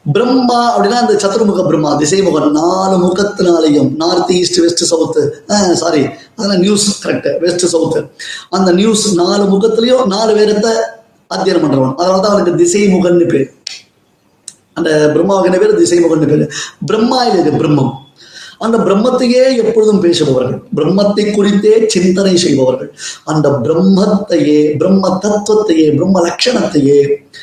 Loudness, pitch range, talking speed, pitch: -11 LUFS, 160-210 Hz, 125 wpm, 185 Hz